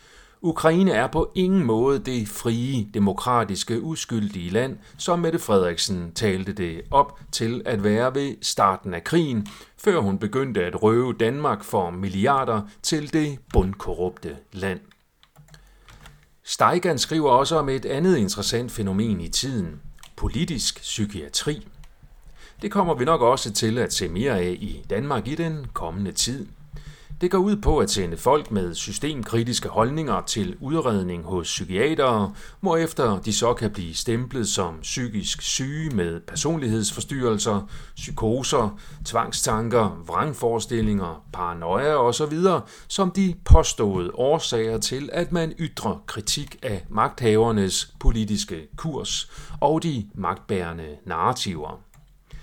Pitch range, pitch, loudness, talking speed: 100-150 Hz, 115 Hz, -23 LUFS, 125 wpm